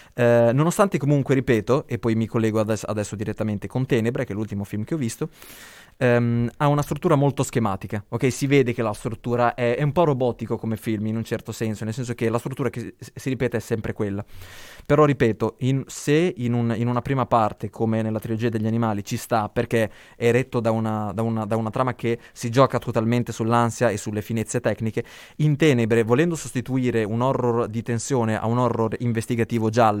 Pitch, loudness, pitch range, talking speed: 120 Hz, -23 LUFS, 110-125 Hz, 210 wpm